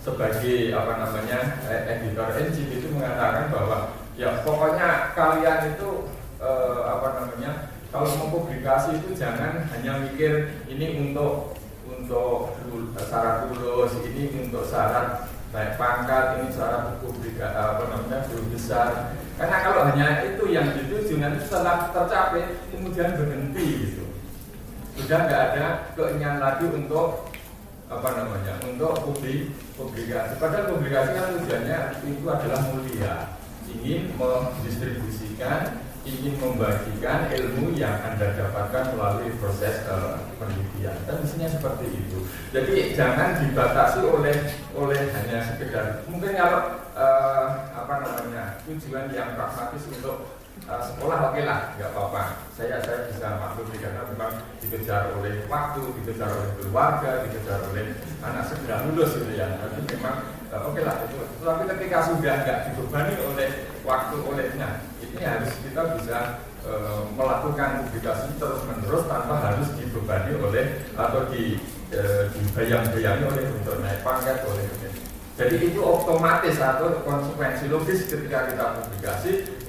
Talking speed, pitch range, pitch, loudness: 125 wpm, 110-145 Hz, 130 Hz, -26 LUFS